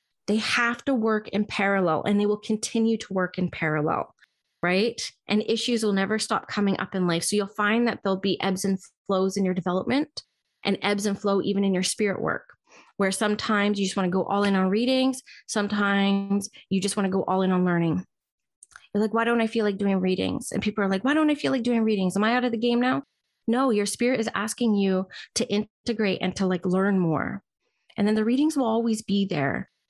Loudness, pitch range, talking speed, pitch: -25 LUFS, 195-225 Hz, 230 wpm, 205 Hz